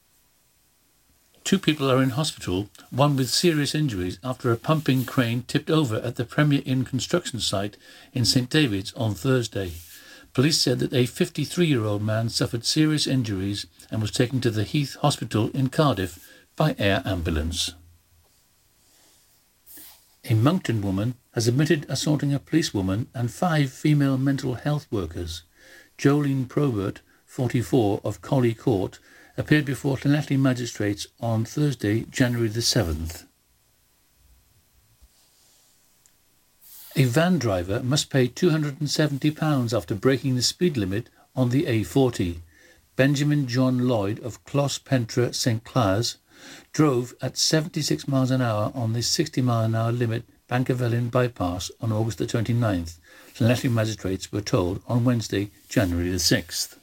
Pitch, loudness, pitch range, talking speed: 125 Hz, -24 LUFS, 105-140 Hz, 135 wpm